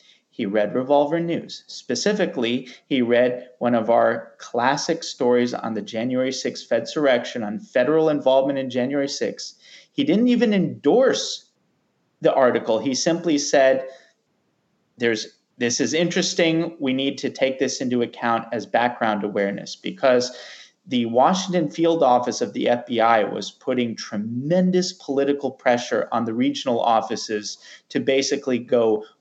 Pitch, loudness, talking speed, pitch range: 135 Hz, -21 LUFS, 140 wpm, 120-165 Hz